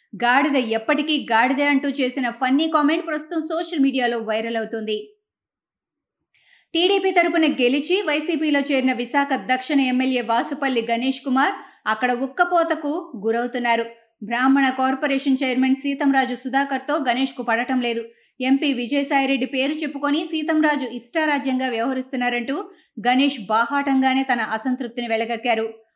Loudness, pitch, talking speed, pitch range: -21 LUFS, 265 Hz, 110 wpm, 245-290 Hz